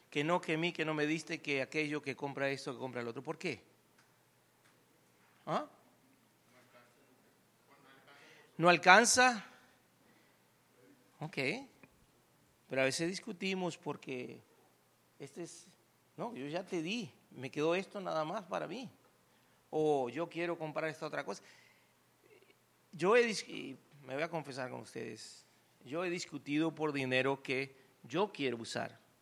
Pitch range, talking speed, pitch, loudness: 135-175 Hz, 135 wpm, 155 Hz, -35 LUFS